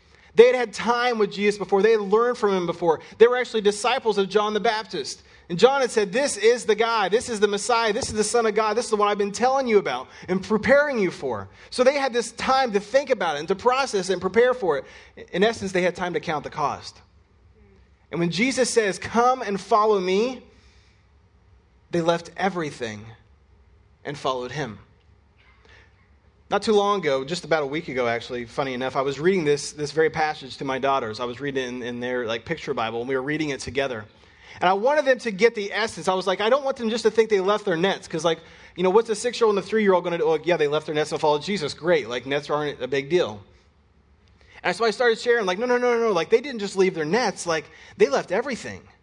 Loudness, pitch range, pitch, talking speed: -23 LUFS, 140-225 Hz, 190 Hz, 245 wpm